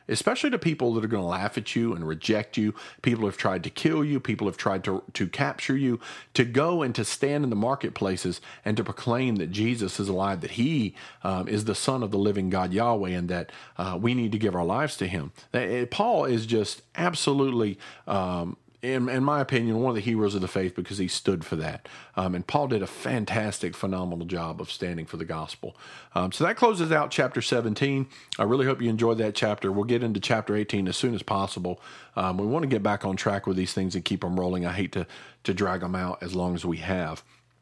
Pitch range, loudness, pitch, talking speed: 95-120 Hz, -27 LUFS, 105 Hz, 235 wpm